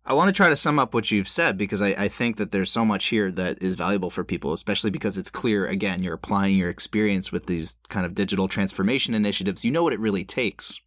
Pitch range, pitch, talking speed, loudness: 95-105 Hz, 100 Hz, 255 wpm, -23 LUFS